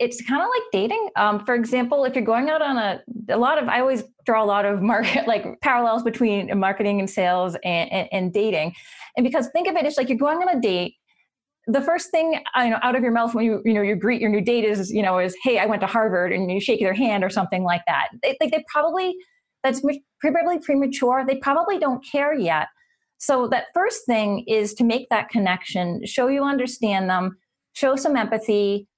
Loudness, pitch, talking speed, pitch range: -22 LUFS, 235 Hz, 230 wpm, 205-285 Hz